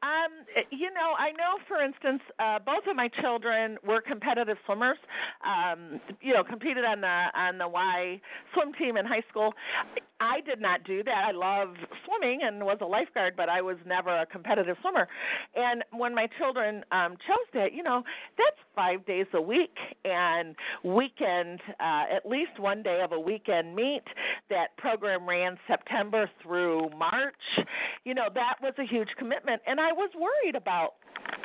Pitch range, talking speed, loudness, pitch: 185-285 Hz, 175 wpm, -29 LUFS, 225 Hz